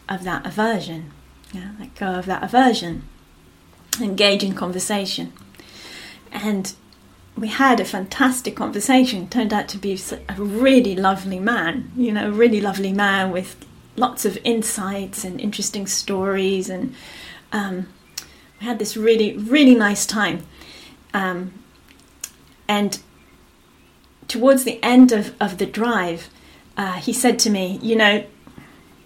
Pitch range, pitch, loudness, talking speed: 190-230 Hz, 205 Hz, -19 LUFS, 130 wpm